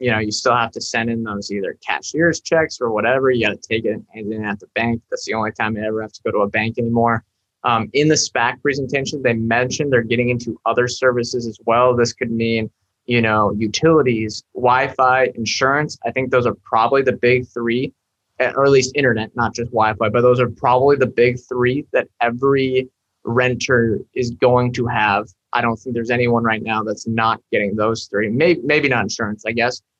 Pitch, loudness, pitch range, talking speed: 120 Hz, -18 LUFS, 110-130 Hz, 215 wpm